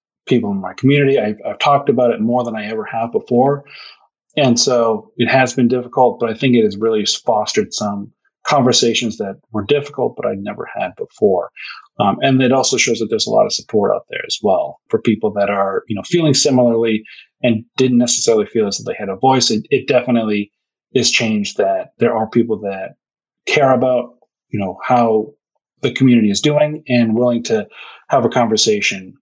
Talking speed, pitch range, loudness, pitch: 195 wpm, 110-135 Hz, -16 LUFS, 120 Hz